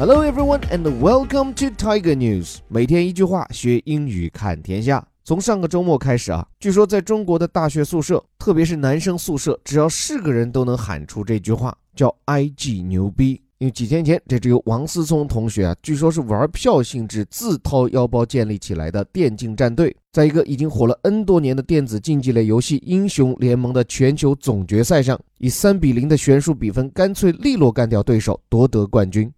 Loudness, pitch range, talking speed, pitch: -18 LUFS, 115-165 Hz, 350 characters per minute, 135 Hz